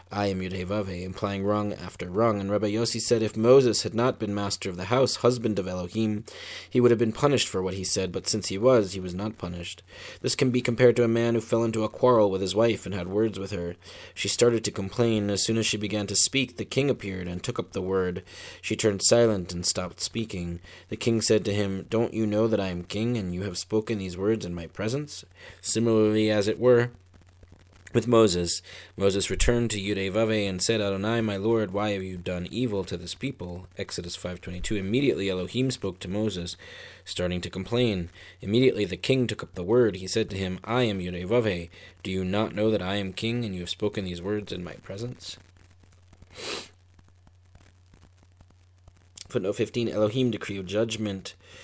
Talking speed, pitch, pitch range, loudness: 205 wpm, 100 Hz, 90-115 Hz, -25 LUFS